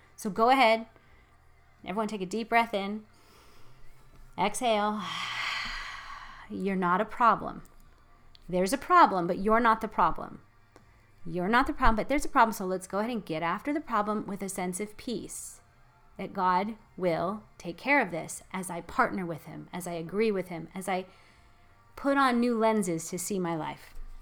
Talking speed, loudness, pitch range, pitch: 175 wpm, -29 LUFS, 170-225 Hz, 195 Hz